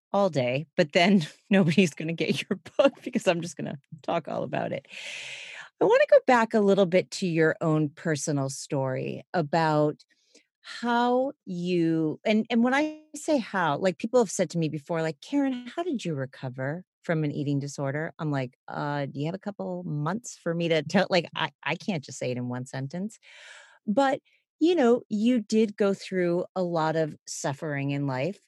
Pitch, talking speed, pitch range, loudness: 180 Hz, 200 wpm, 155-225 Hz, -27 LUFS